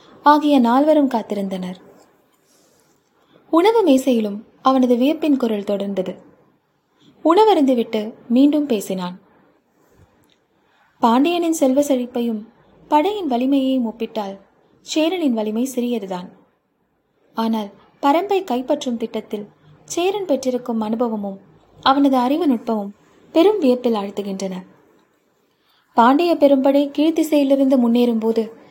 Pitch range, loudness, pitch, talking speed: 220-290 Hz, -18 LUFS, 245 Hz, 80 wpm